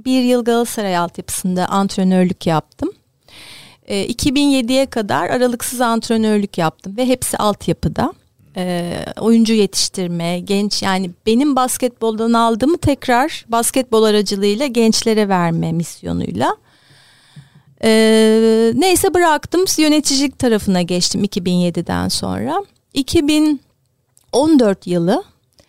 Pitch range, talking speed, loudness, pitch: 180-255 Hz, 85 wpm, -16 LUFS, 220 Hz